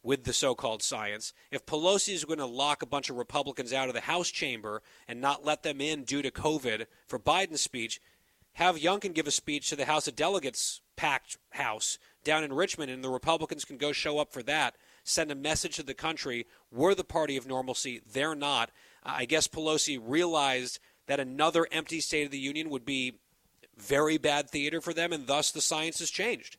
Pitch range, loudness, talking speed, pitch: 135-160 Hz, -30 LUFS, 210 wpm, 150 Hz